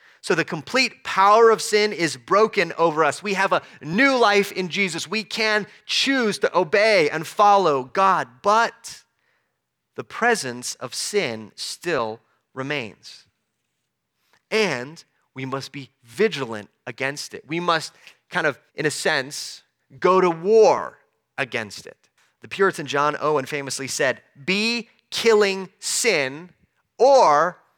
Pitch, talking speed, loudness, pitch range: 180 Hz, 130 wpm, -21 LUFS, 140-210 Hz